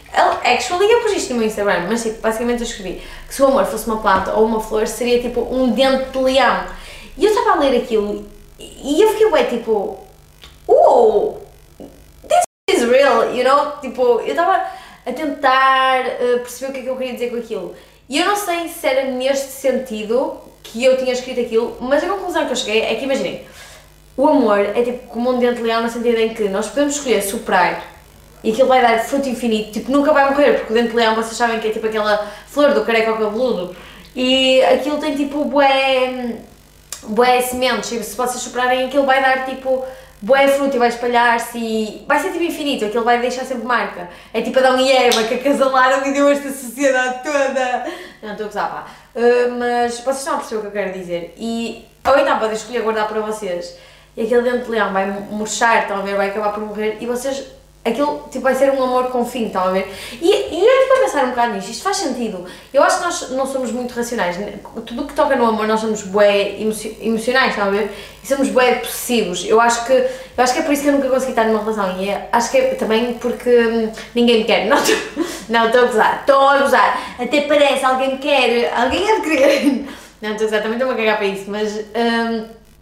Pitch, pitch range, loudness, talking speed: 245 Hz, 220-270 Hz, -17 LUFS, 220 wpm